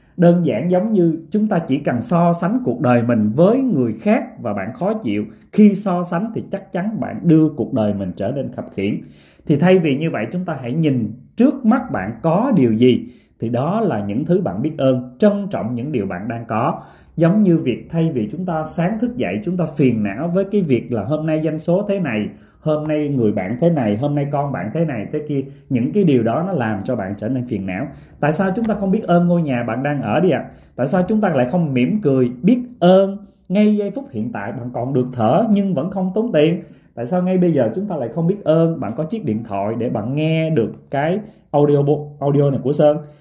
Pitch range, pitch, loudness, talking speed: 130-195 Hz, 160 Hz, -18 LUFS, 250 wpm